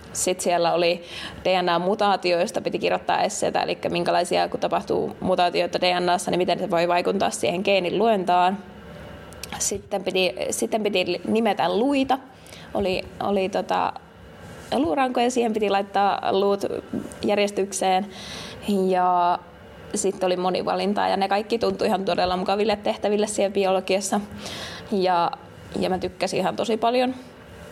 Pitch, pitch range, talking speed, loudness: 190 Hz, 180-210 Hz, 125 wpm, -23 LUFS